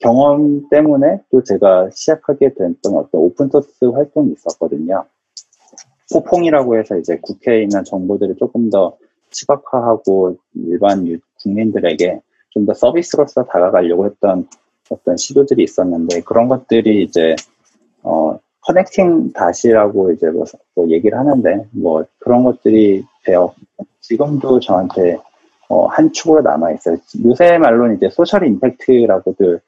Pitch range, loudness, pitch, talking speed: 100-155 Hz, -14 LUFS, 120 Hz, 300 characters per minute